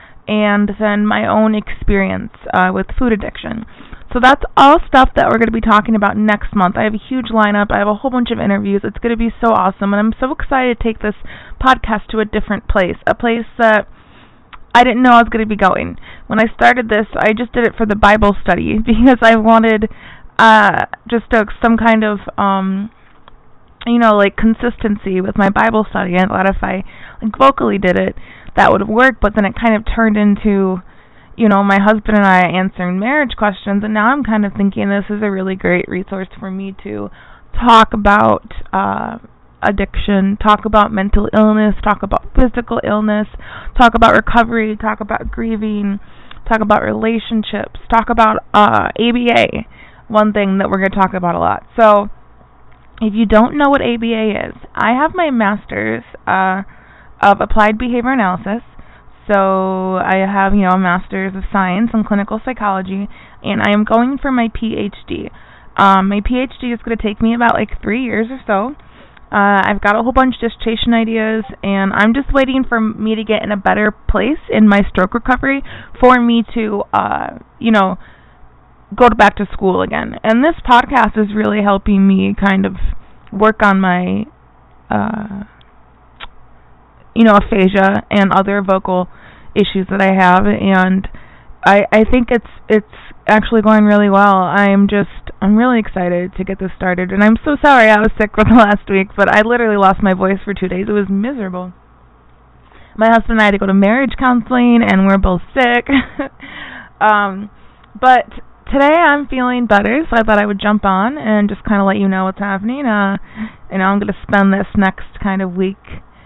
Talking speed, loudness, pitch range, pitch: 190 wpm, -13 LUFS, 195-230 Hz, 210 Hz